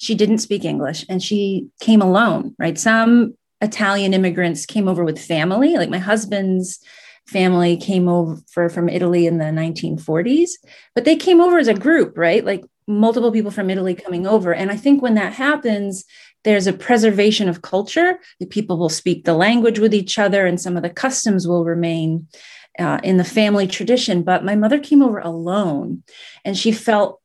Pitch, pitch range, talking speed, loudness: 200 Hz, 175-220 Hz, 185 wpm, -17 LUFS